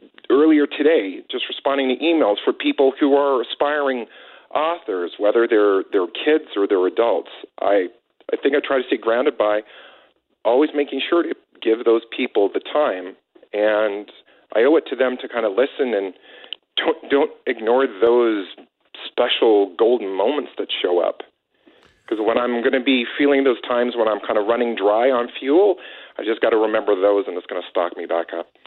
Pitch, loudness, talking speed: 140 Hz, -19 LUFS, 185 wpm